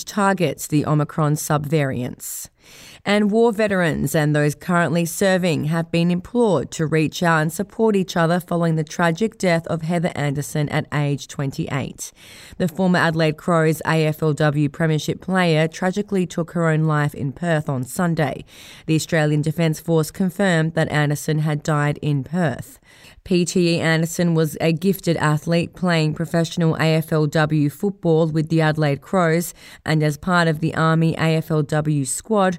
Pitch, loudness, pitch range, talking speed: 160 Hz, -20 LUFS, 150-175 Hz, 145 wpm